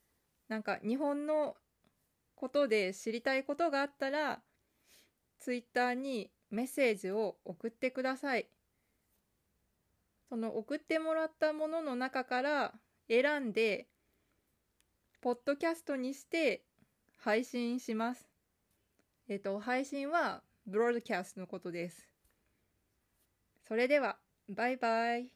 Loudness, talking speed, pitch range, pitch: -35 LUFS, 235 characters per minute, 220-280 Hz, 245 Hz